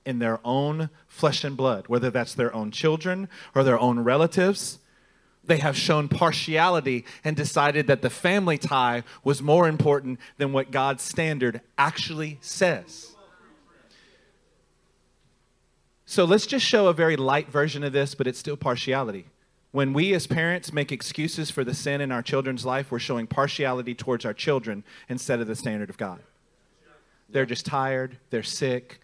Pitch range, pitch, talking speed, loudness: 125-155 Hz, 140 Hz, 160 wpm, -25 LUFS